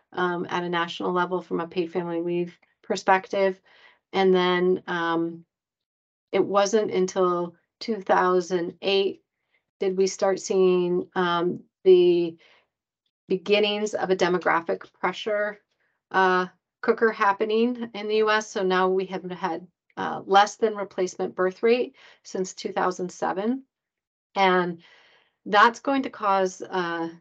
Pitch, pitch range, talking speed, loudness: 185 Hz, 180-205 Hz, 120 wpm, -24 LUFS